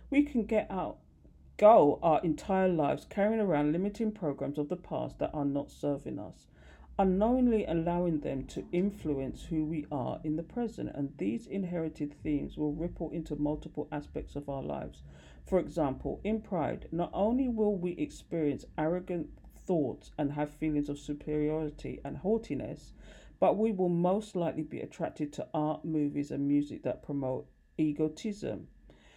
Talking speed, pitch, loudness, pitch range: 155 wpm, 155 Hz, -32 LUFS, 145-185 Hz